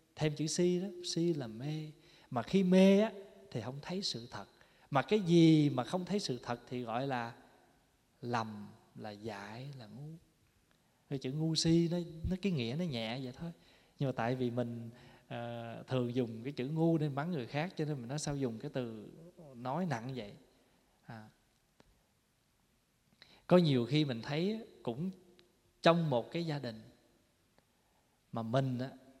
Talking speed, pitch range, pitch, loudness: 175 wpm, 120-170 Hz, 135 Hz, -35 LUFS